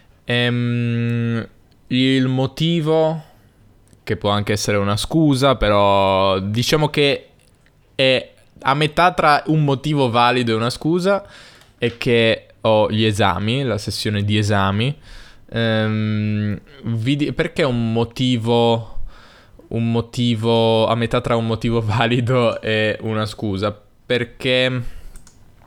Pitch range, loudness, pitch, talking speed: 110-130 Hz, -18 LUFS, 115 Hz, 110 wpm